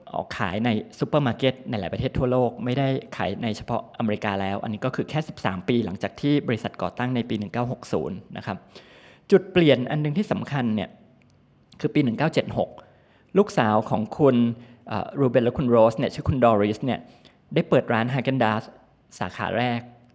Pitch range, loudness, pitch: 110-135 Hz, -24 LUFS, 120 Hz